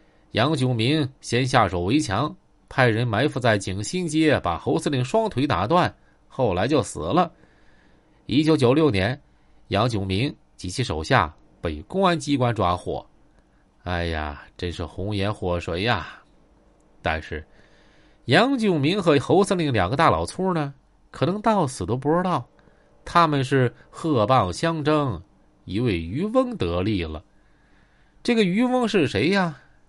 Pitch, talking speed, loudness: 130 Hz, 205 characters per minute, -23 LUFS